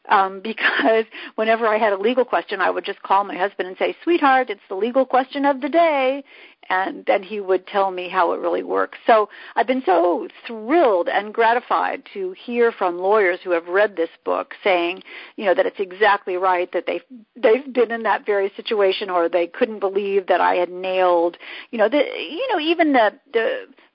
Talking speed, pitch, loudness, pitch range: 205 wpm, 220 Hz, -20 LUFS, 190-270 Hz